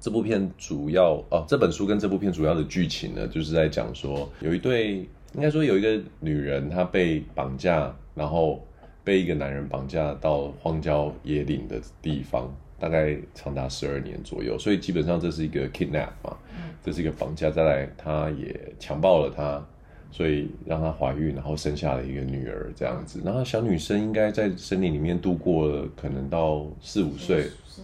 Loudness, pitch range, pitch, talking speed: -26 LUFS, 70-90 Hz, 80 Hz, 290 characters per minute